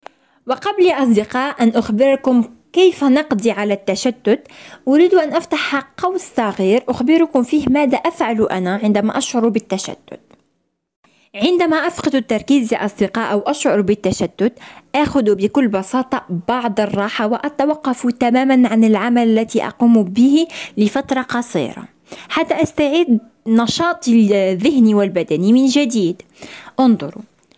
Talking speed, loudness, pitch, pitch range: 115 wpm, -16 LUFS, 245 Hz, 215-285 Hz